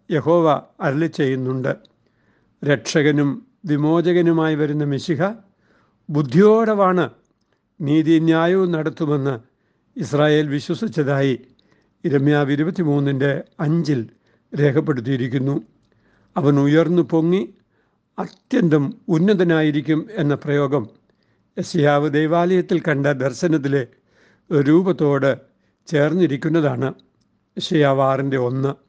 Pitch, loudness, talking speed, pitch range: 150 Hz, -19 LUFS, 65 wpm, 140-165 Hz